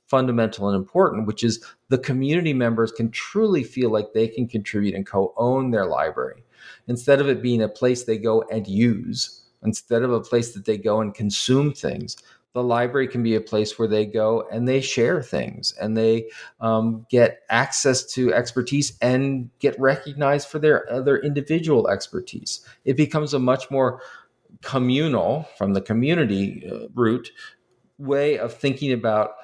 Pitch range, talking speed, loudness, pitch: 110-135 Hz, 170 wpm, -22 LUFS, 120 Hz